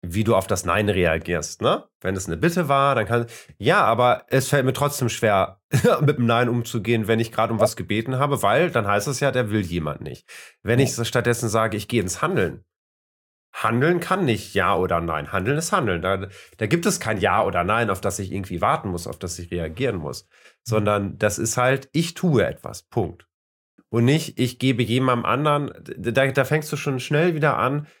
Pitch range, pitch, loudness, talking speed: 95-135 Hz, 115 Hz, -22 LUFS, 210 wpm